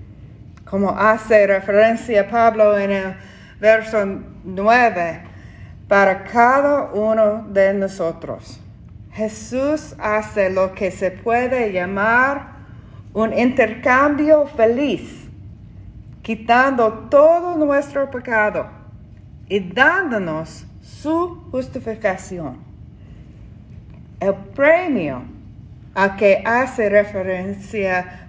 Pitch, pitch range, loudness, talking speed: 215 Hz, 195-250 Hz, -17 LUFS, 80 wpm